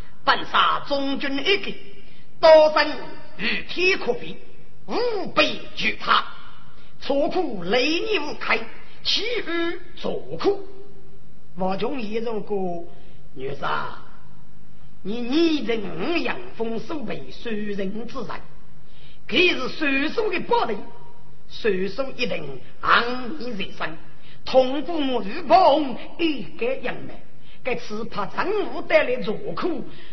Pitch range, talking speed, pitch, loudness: 215-335 Hz, 150 characters per minute, 265 Hz, -23 LUFS